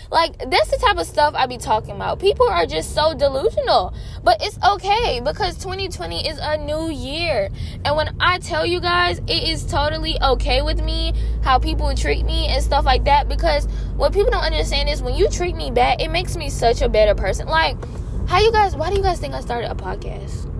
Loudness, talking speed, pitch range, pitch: -19 LUFS, 220 wpm, 300-405 Hz, 345 Hz